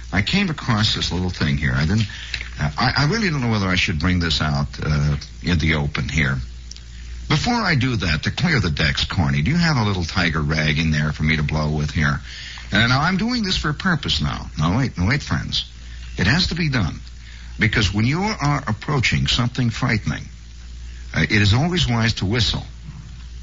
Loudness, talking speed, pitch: -20 LUFS, 210 wpm, 85 Hz